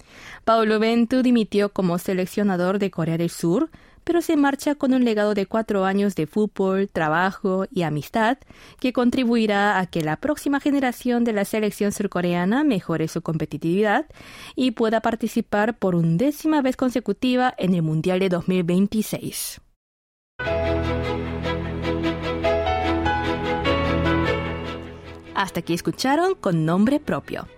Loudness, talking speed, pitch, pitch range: -22 LUFS, 120 wpm, 190 Hz, 155-230 Hz